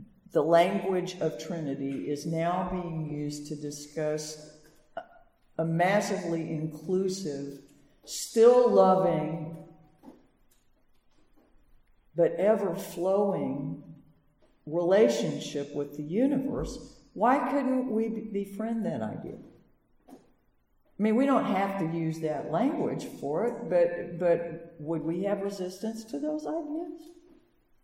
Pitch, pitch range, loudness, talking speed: 180 Hz, 155-225 Hz, -29 LUFS, 105 wpm